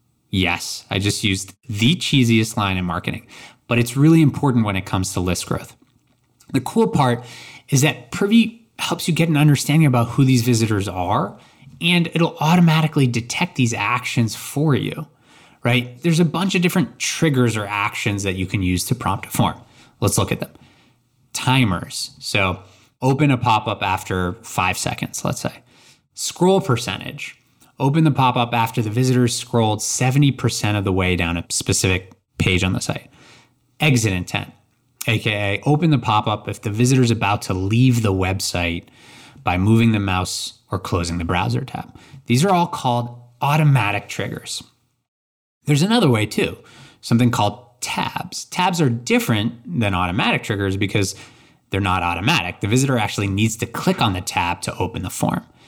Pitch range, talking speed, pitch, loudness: 100-135 Hz, 170 wpm, 120 Hz, -19 LUFS